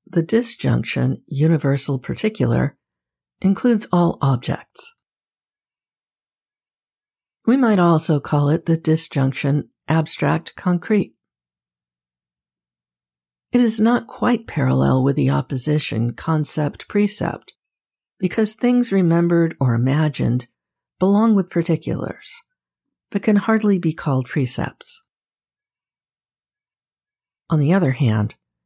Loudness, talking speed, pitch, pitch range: -19 LUFS, 90 wpm, 155 Hz, 125-200 Hz